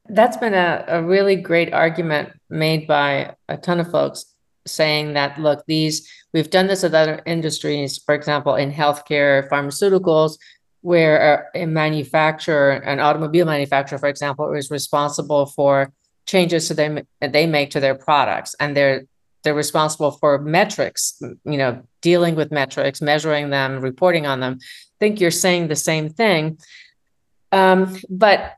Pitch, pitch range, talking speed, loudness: 155 Hz, 145-170 Hz, 150 wpm, -18 LUFS